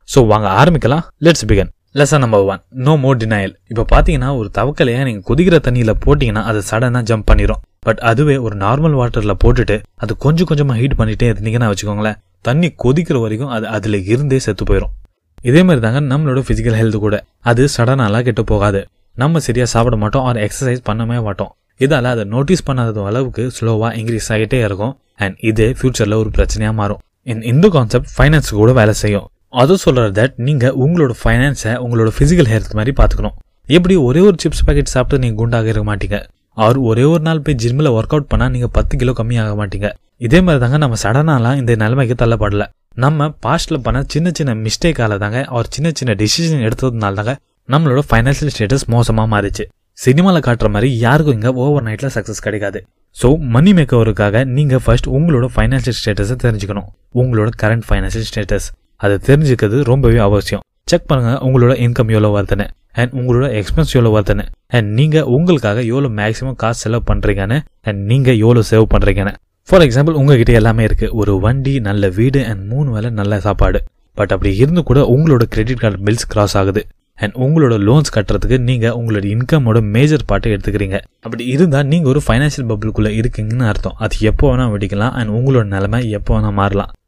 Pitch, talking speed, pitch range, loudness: 115 Hz, 160 wpm, 105-135 Hz, -14 LUFS